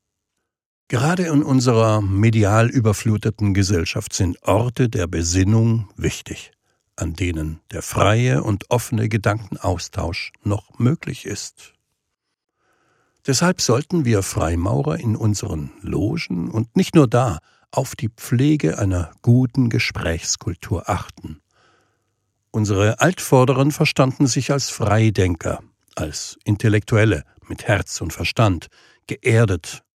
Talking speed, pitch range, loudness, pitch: 105 wpm, 100-130 Hz, -20 LUFS, 110 Hz